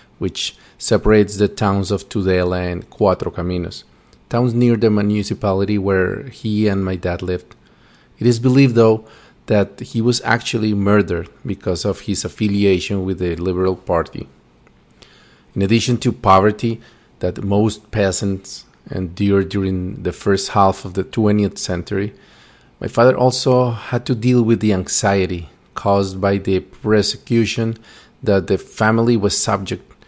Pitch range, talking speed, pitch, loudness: 95-115 Hz, 140 wpm, 100 Hz, -18 LUFS